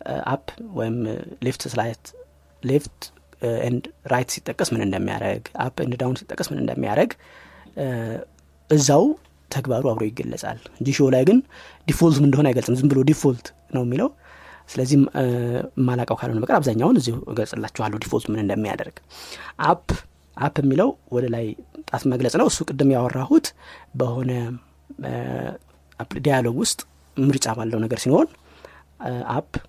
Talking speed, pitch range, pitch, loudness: 120 wpm, 110-140 Hz, 125 Hz, -22 LUFS